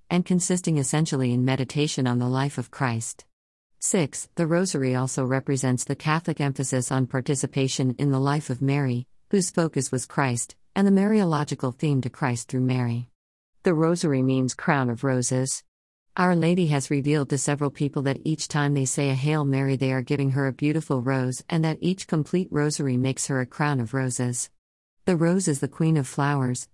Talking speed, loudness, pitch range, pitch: 185 wpm, -25 LUFS, 130-155 Hz, 140 Hz